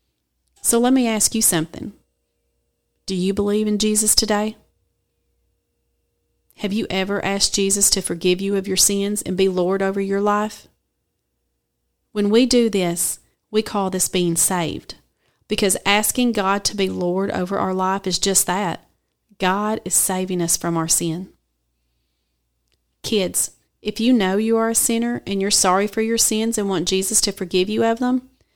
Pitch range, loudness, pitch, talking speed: 180-215 Hz, -19 LUFS, 195 Hz, 165 wpm